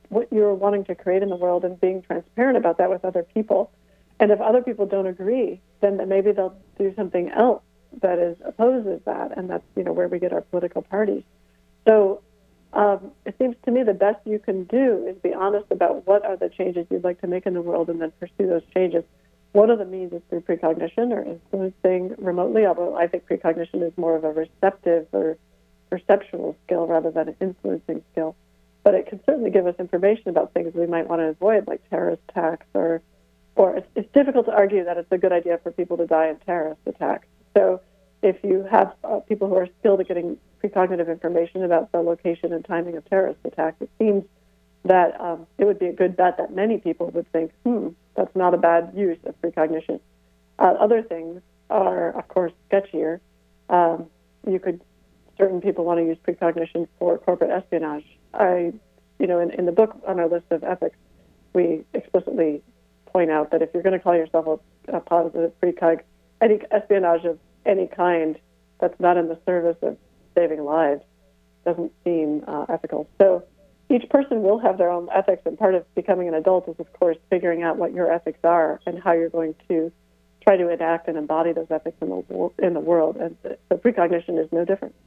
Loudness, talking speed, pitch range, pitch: -22 LUFS, 205 wpm, 165-195 Hz, 175 Hz